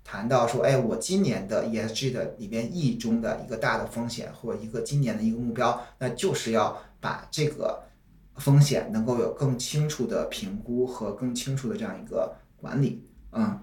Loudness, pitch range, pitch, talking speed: -28 LUFS, 115-150 Hz, 125 Hz, 280 characters per minute